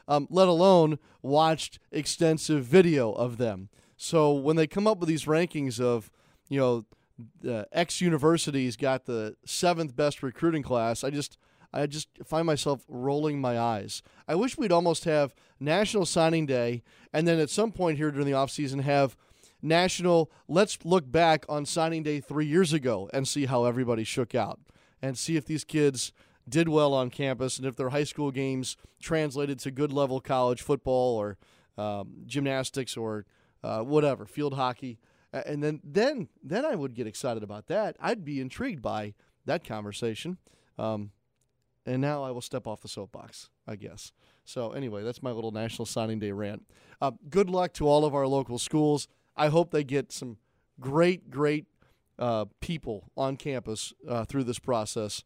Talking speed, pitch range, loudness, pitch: 175 wpm, 120-155 Hz, -28 LUFS, 140 Hz